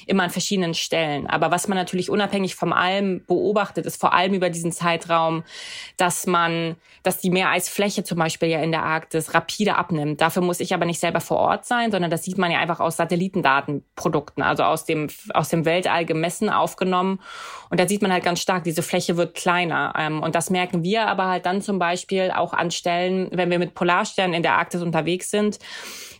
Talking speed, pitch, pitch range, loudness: 200 wpm, 175 Hz, 165-185 Hz, -22 LUFS